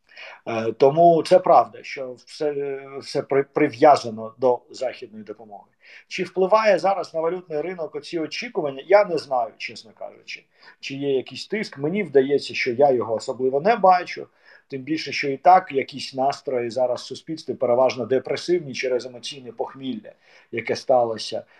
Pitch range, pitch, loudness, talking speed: 130-170 Hz, 140 Hz, -22 LUFS, 140 wpm